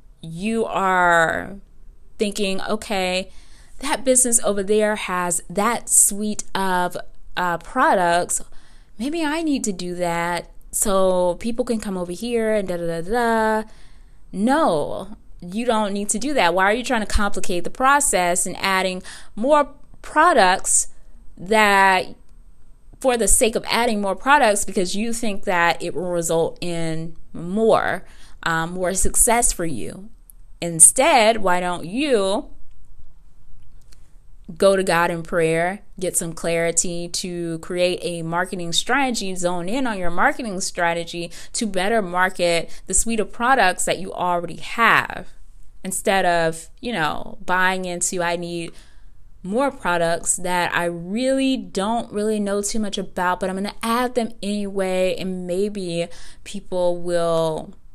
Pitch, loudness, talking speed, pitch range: 190 Hz, -20 LUFS, 140 wpm, 175-220 Hz